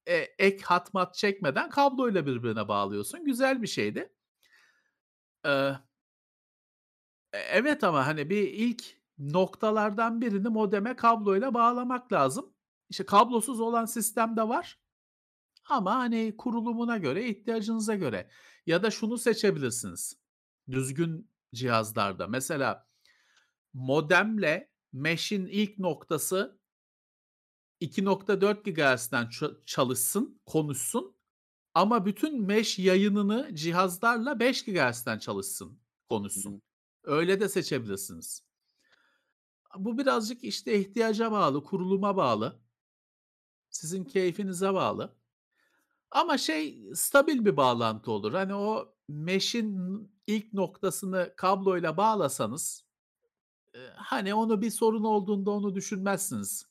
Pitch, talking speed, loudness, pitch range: 200 Hz, 95 wpm, -28 LUFS, 160-230 Hz